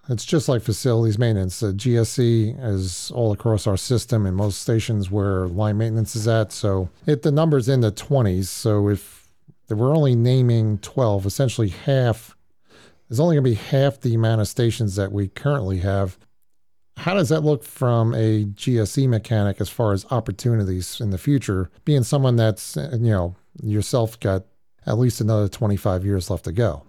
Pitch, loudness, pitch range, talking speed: 110 Hz, -21 LUFS, 100-125 Hz, 175 wpm